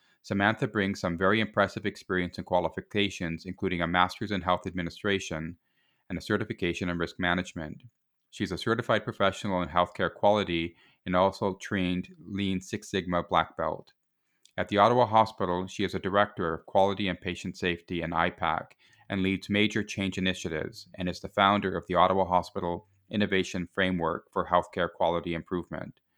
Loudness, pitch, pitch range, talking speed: -29 LUFS, 95 Hz, 90-100 Hz, 160 wpm